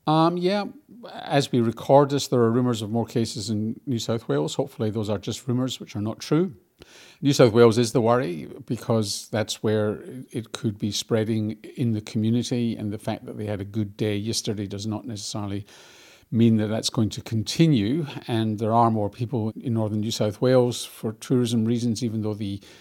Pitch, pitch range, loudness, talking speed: 115 Hz, 110-125 Hz, -24 LUFS, 195 wpm